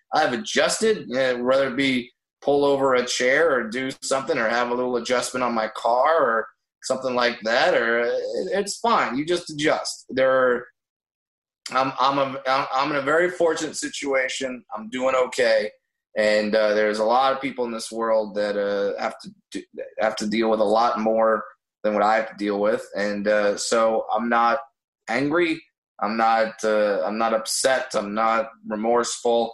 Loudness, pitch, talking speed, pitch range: -22 LUFS, 125 Hz, 180 wpm, 110-140 Hz